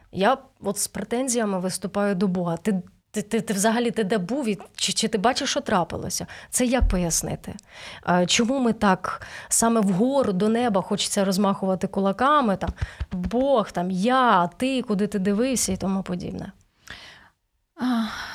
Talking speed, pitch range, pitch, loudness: 145 wpm, 195-240 Hz, 210 Hz, -23 LUFS